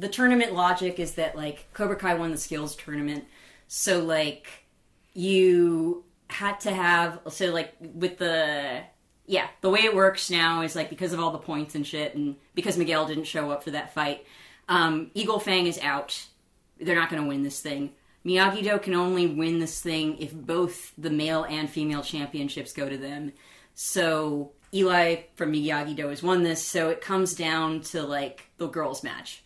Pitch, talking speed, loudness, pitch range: 165 Hz, 185 wpm, -26 LUFS, 150-180 Hz